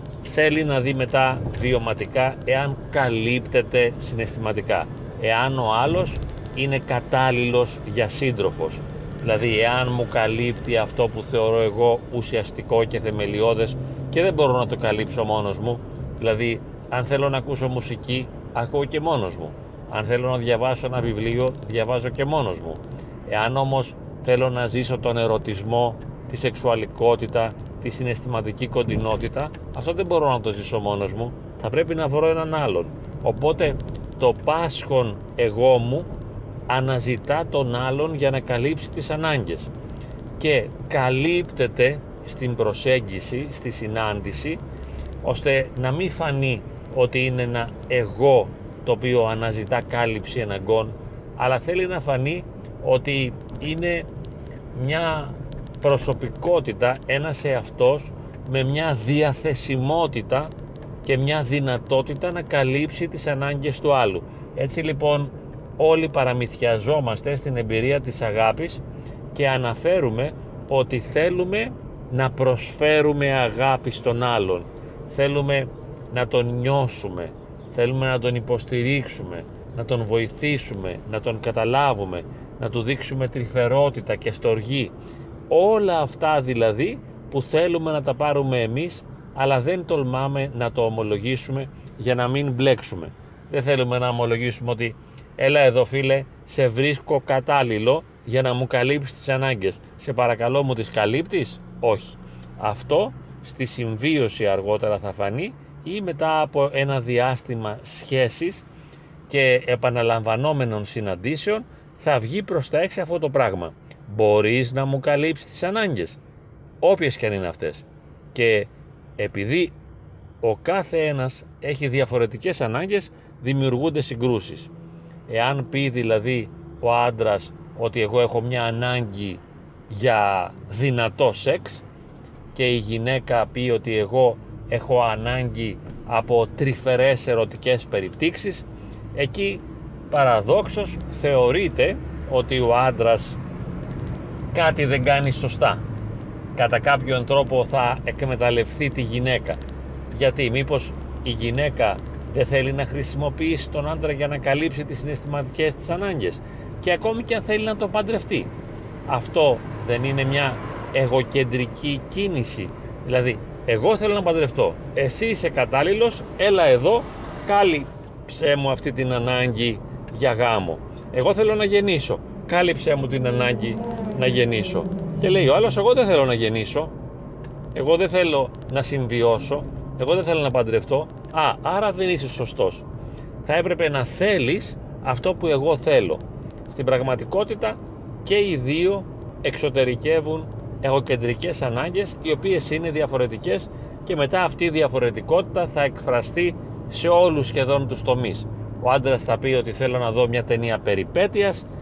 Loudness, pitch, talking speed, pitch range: -22 LUFS, 130 Hz, 125 wpm, 120-145 Hz